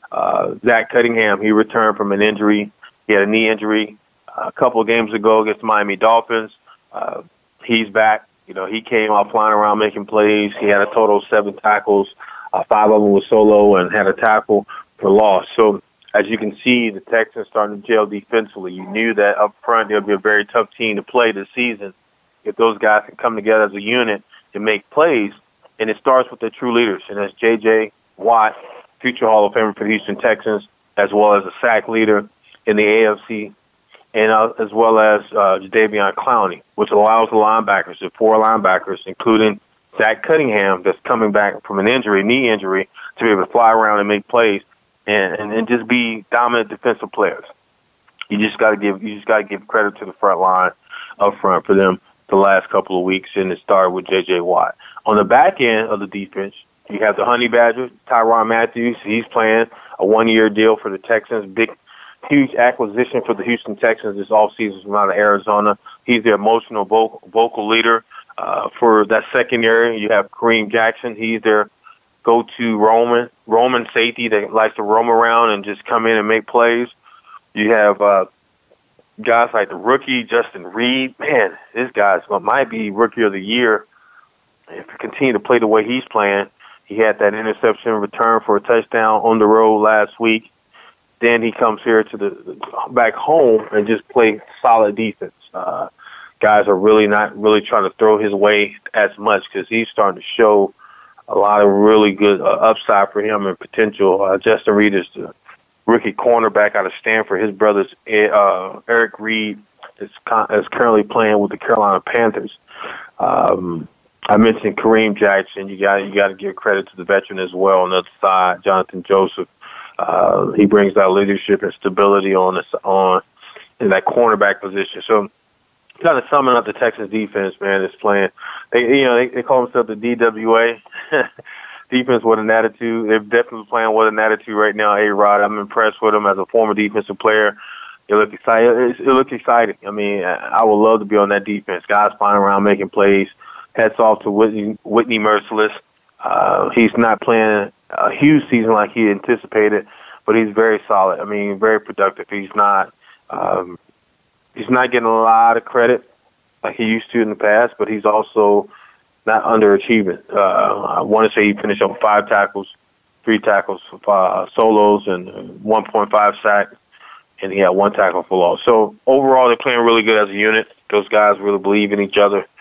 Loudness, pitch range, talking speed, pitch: -15 LUFS, 105-115 Hz, 195 wpm, 110 Hz